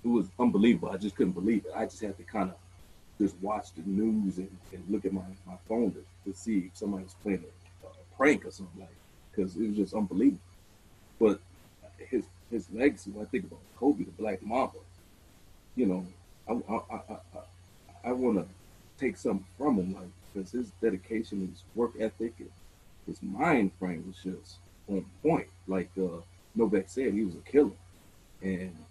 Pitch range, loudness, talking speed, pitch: 90-105 Hz, -32 LUFS, 190 wpm, 95 Hz